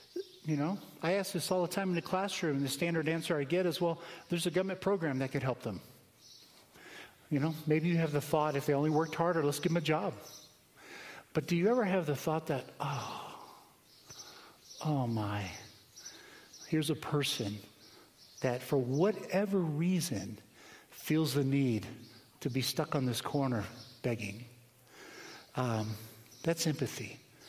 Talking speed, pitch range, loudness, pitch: 165 wpm, 125-170 Hz, -34 LUFS, 150 Hz